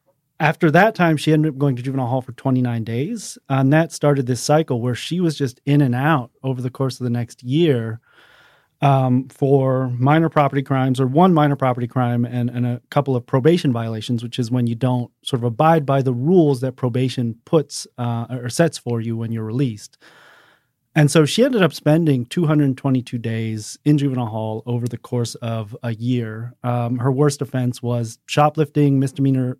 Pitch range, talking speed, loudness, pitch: 120-150 Hz, 195 wpm, -19 LUFS, 130 Hz